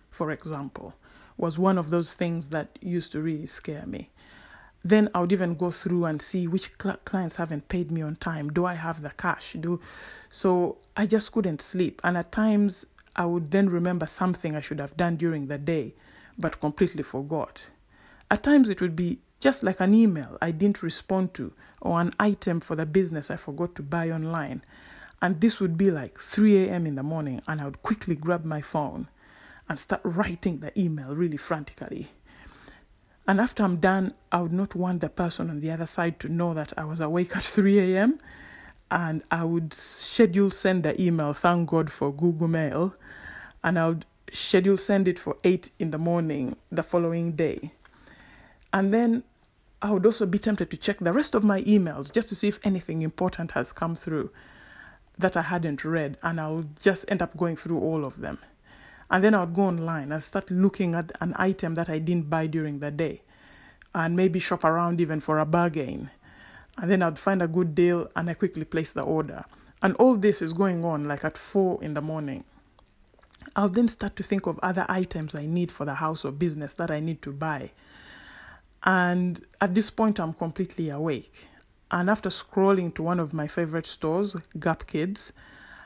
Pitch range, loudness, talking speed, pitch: 160-190 Hz, -26 LUFS, 195 wpm, 175 Hz